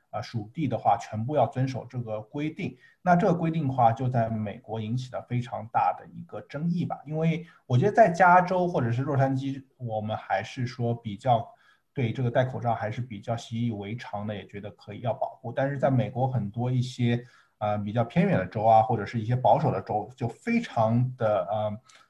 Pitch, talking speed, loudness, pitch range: 120 Hz, 310 characters per minute, -27 LUFS, 110-135 Hz